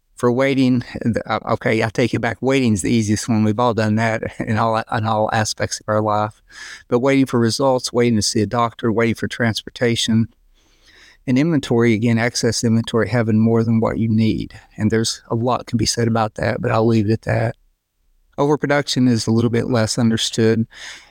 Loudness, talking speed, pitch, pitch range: -18 LUFS, 195 wpm, 115 Hz, 110-120 Hz